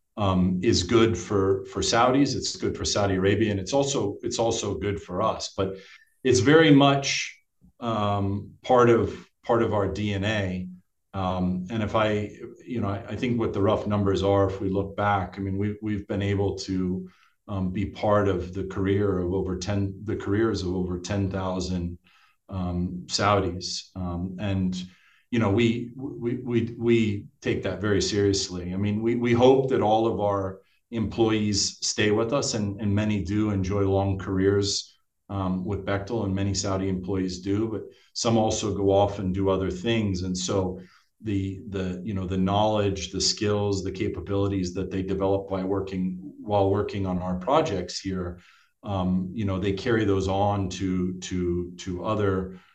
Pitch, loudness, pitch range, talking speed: 100 Hz, -25 LUFS, 95-105 Hz, 175 wpm